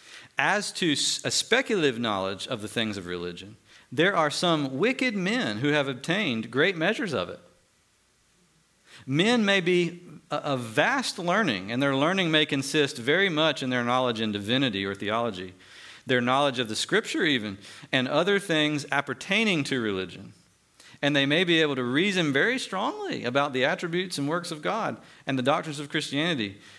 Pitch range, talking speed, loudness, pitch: 120-170 Hz, 170 wpm, -25 LUFS, 140 Hz